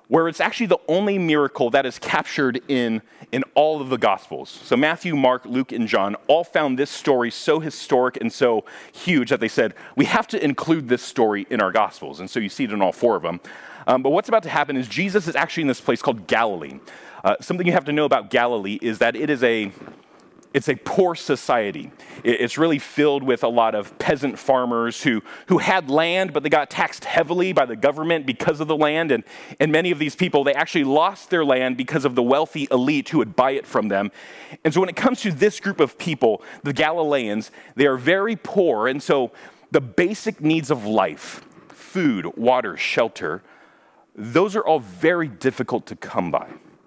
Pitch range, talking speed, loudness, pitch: 130-170 Hz, 210 wpm, -21 LUFS, 150 Hz